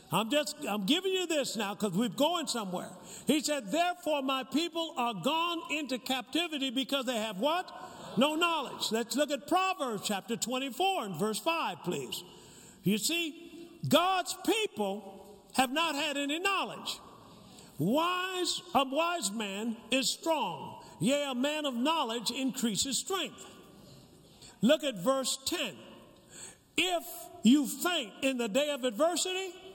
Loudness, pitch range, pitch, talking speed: -31 LUFS, 235-330 Hz, 280 Hz, 135 wpm